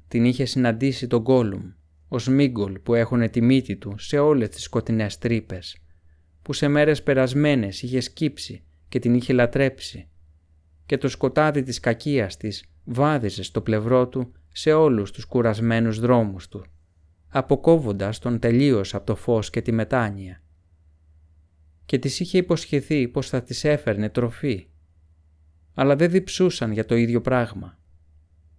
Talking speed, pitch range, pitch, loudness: 145 wpm, 90-130 Hz, 115 Hz, -22 LUFS